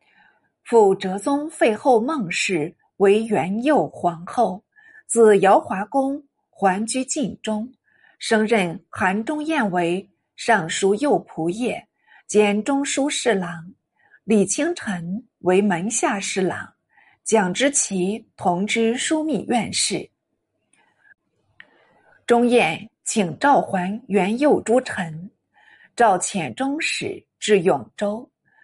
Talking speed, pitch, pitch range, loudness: 145 characters per minute, 220 Hz, 195-275 Hz, -21 LUFS